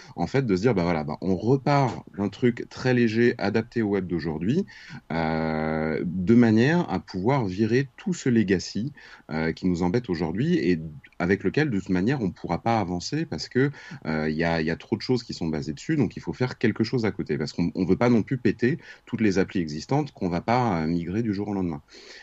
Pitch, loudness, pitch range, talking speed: 95 Hz, -25 LUFS, 85-120 Hz, 235 wpm